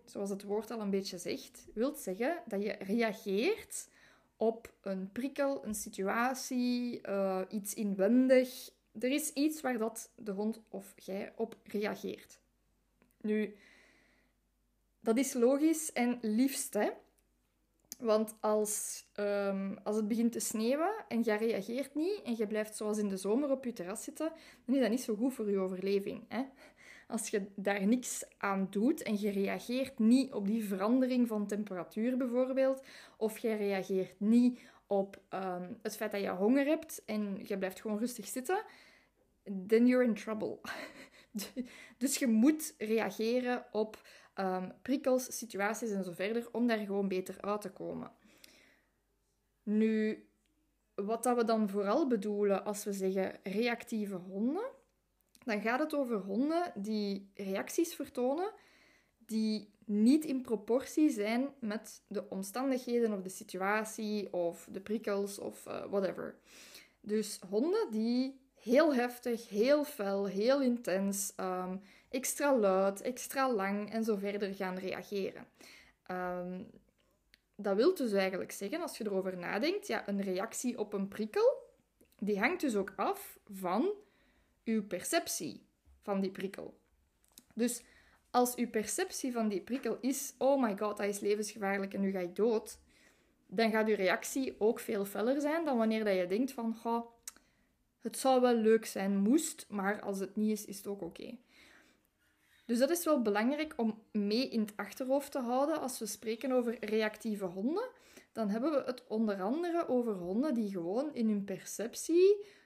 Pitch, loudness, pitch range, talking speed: 220 Hz, -34 LUFS, 200-255 Hz, 155 wpm